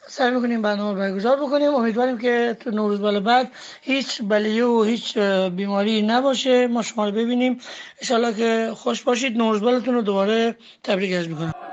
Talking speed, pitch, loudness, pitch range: 165 wpm, 230 Hz, -21 LUFS, 210-250 Hz